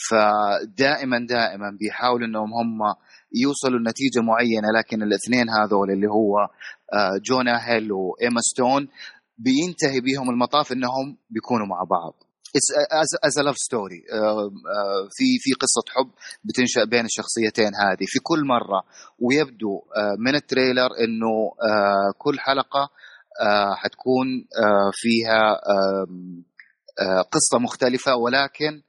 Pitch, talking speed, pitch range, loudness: 115 Hz, 105 wpm, 105-130 Hz, -21 LUFS